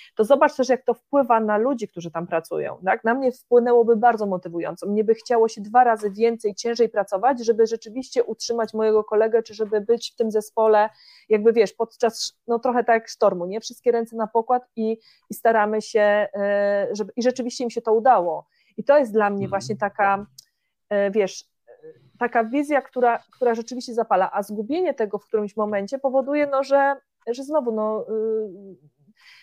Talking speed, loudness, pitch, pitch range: 175 wpm, -22 LUFS, 225 Hz, 210-240 Hz